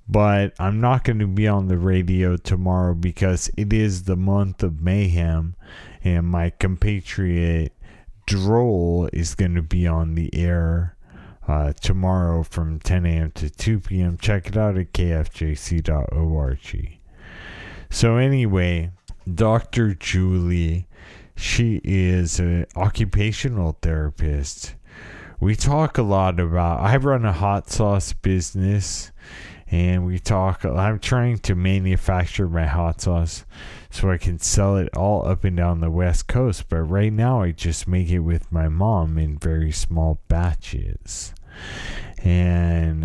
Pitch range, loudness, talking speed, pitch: 85-100 Hz, -21 LUFS, 135 wpm, 90 Hz